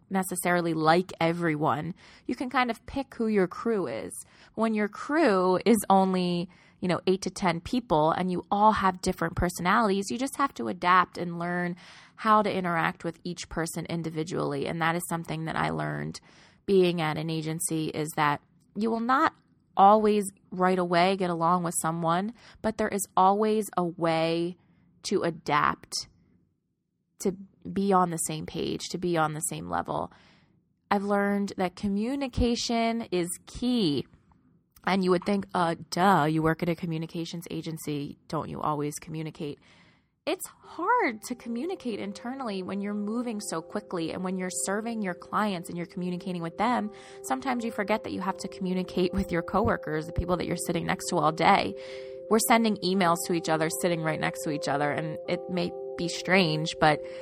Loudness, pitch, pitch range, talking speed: -28 LUFS, 180 Hz, 165-205 Hz, 175 wpm